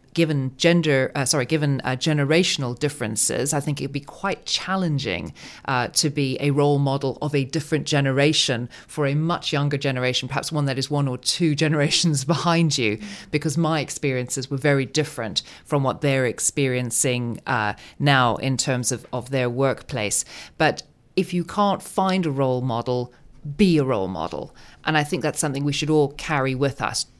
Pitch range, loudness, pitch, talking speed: 130-155 Hz, -22 LUFS, 140 Hz, 180 wpm